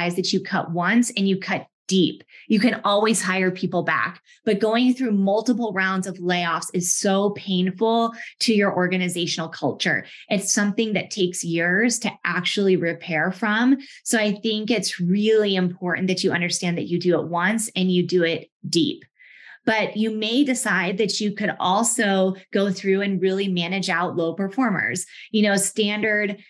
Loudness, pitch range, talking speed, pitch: -22 LUFS, 180-220 Hz, 170 wpm, 195 Hz